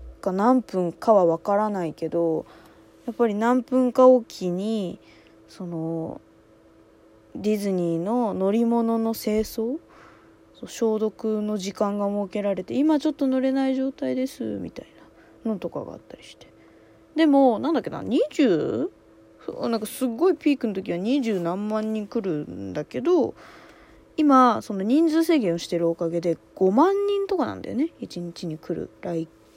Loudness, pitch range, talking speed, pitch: -24 LUFS, 170-255 Hz, 265 characters per minute, 210 Hz